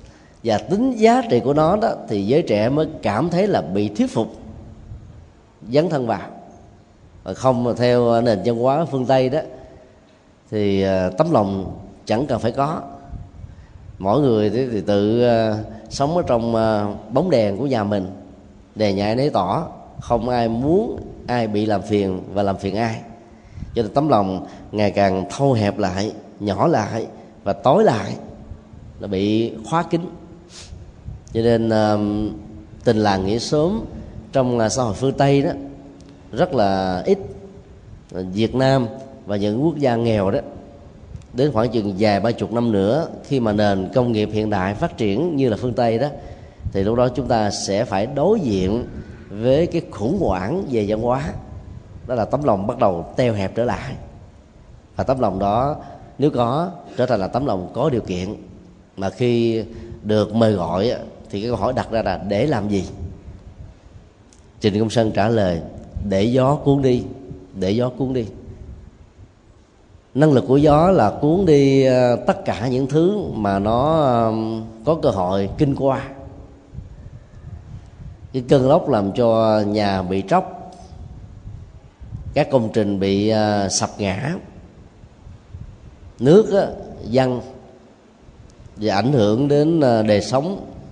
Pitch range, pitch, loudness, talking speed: 100-130 Hz, 110 Hz, -19 LUFS, 155 wpm